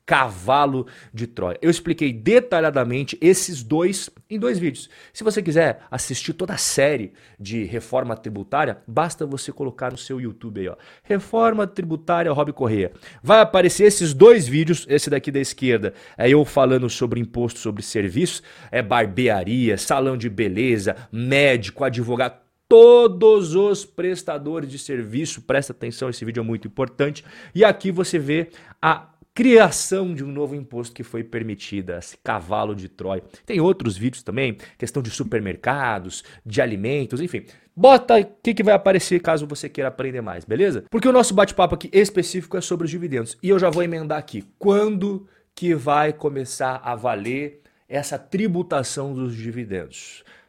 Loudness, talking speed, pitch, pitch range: -20 LUFS, 155 wpm, 145 Hz, 120-180 Hz